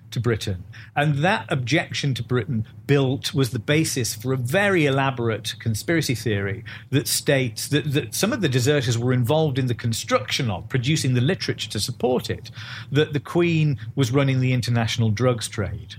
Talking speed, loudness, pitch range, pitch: 175 wpm, -22 LUFS, 115-145 Hz, 125 Hz